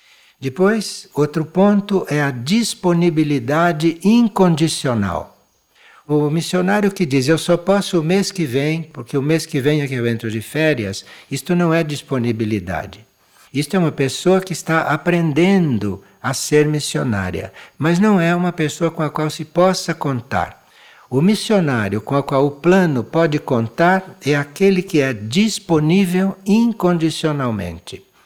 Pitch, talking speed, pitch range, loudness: 155 Hz, 145 wpm, 135-180 Hz, -17 LUFS